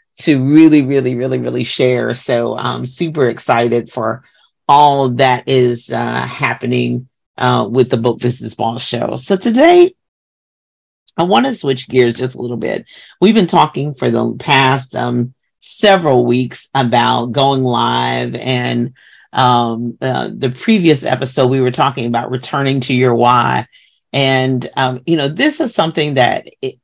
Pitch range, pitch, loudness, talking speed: 120-140 Hz, 130 Hz, -14 LUFS, 155 wpm